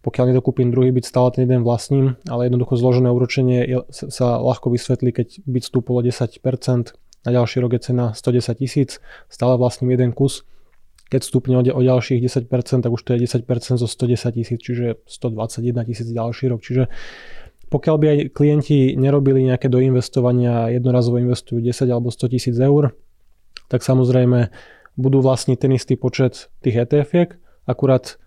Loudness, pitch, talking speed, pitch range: -18 LUFS, 125 Hz, 160 wpm, 120-130 Hz